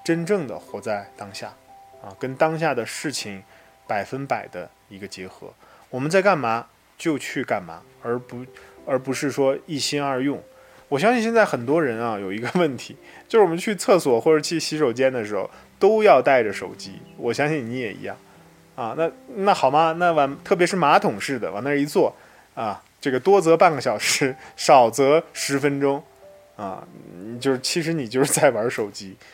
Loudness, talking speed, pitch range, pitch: -21 LUFS, 260 characters per minute, 125-165 Hz, 140 Hz